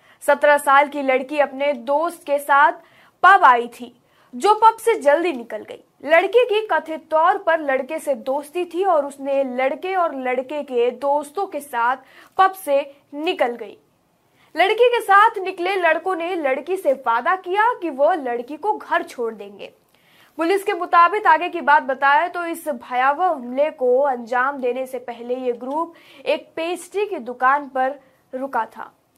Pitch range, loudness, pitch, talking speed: 265-350 Hz, -19 LUFS, 295 Hz, 165 wpm